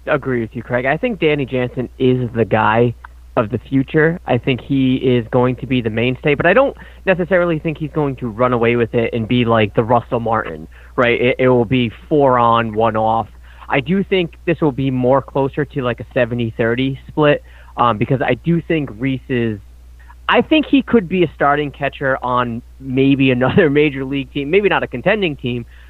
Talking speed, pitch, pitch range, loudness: 210 wpm, 130 Hz, 120-150 Hz, -16 LUFS